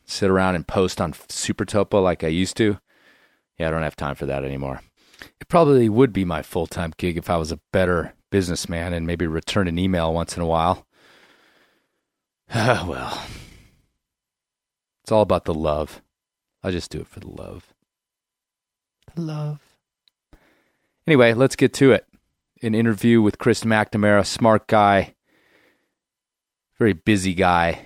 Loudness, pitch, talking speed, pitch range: -21 LUFS, 95 Hz, 155 wpm, 85-110 Hz